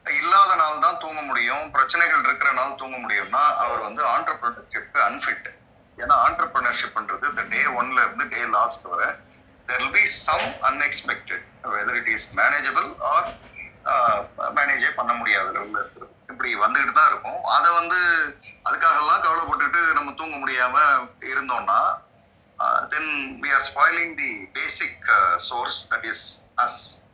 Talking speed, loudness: 65 wpm, -20 LUFS